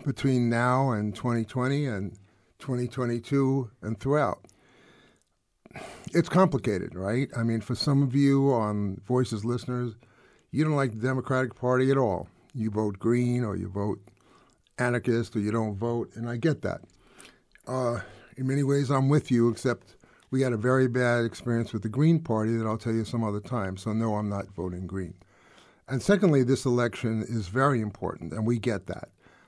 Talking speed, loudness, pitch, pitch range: 175 wpm, -27 LUFS, 120 Hz, 110-130 Hz